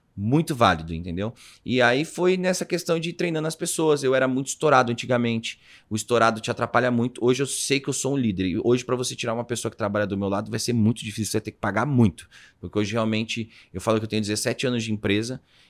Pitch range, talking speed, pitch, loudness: 110-130 Hz, 250 wpm, 120 Hz, -24 LUFS